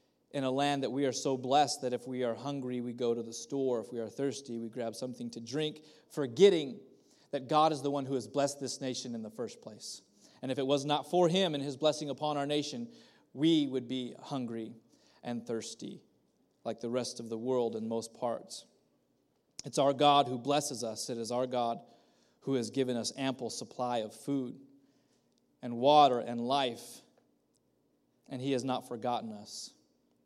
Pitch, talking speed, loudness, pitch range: 130 Hz, 195 wpm, -33 LUFS, 120-145 Hz